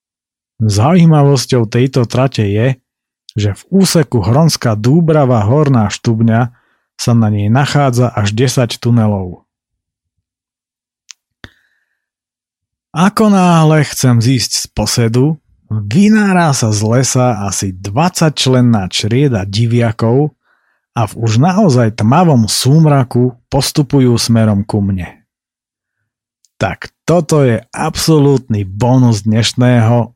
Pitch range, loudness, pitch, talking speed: 110-145 Hz, -12 LUFS, 125 Hz, 95 wpm